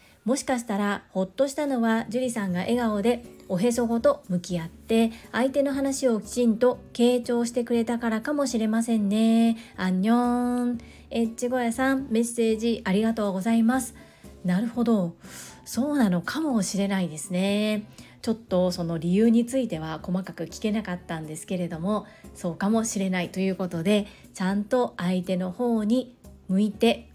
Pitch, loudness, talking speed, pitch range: 225 Hz, -26 LUFS, 345 characters per minute, 190-240 Hz